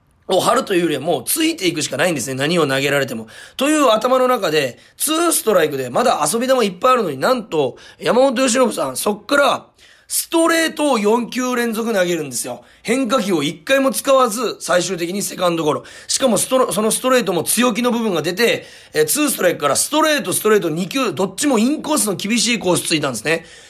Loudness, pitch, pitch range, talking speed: -17 LUFS, 230 Hz, 175-265 Hz, 440 characters per minute